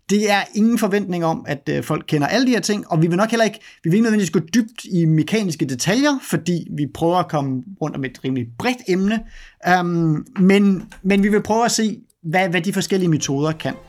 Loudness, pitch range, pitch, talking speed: -19 LUFS, 160-215 Hz, 185 Hz, 220 wpm